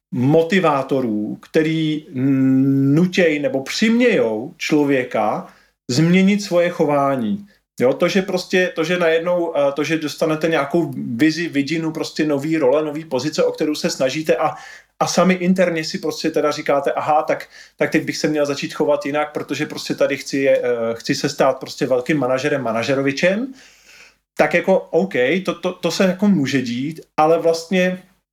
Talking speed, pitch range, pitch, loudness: 155 wpm, 145-175 Hz, 160 Hz, -18 LUFS